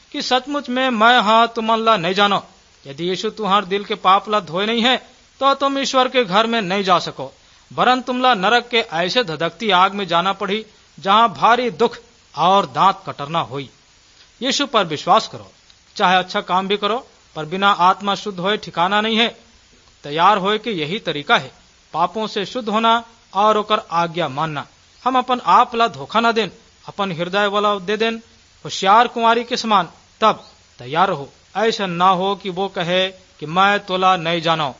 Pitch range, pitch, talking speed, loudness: 180-230 Hz, 205 Hz, 180 wpm, -17 LUFS